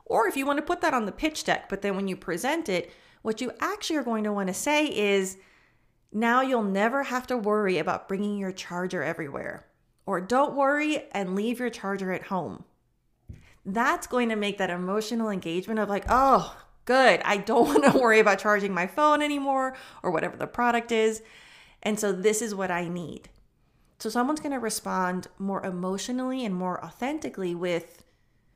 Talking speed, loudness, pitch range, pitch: 190 wpm, -26 LUFS, 190-255 Hz, 215 Hz